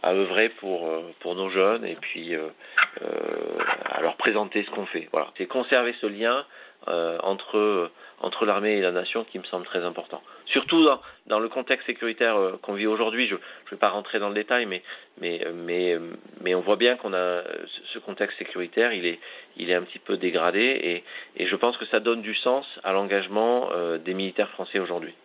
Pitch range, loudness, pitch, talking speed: 90-115 Hz, -26 LUFS, 100 Hz, 205 wpm